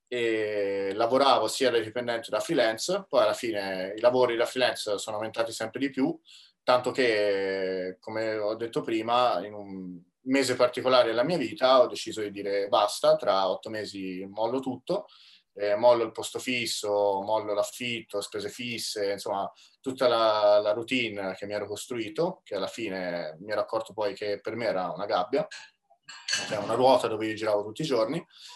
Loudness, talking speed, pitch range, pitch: -27 LUFS, 175 wpm, 100-120 Hz, 110 Hz